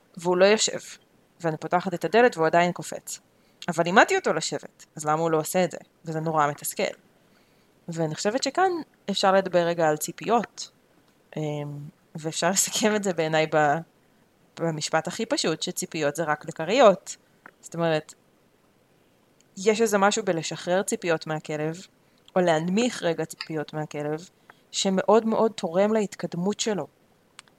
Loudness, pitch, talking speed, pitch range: -25 LUFS, 170 Hz, 135 wpm, 160-200 Hz